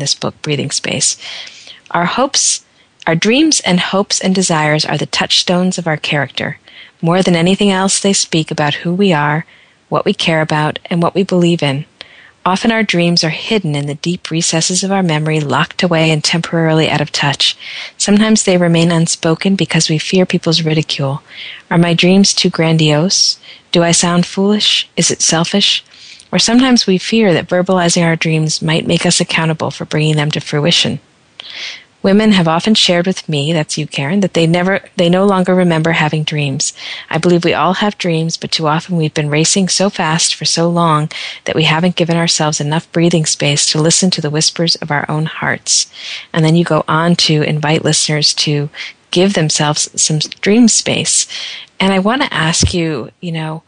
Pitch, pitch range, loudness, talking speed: 170 Hz, 155-185 Hz, -12 LUFS, 190 wpm